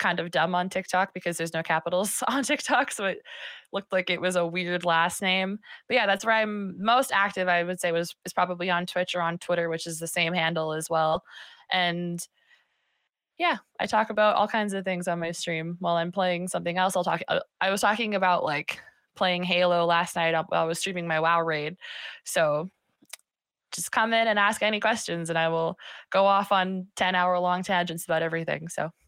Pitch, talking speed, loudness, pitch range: 180 Hz, 210 wpm, -26 LUFS, 170-195 Hz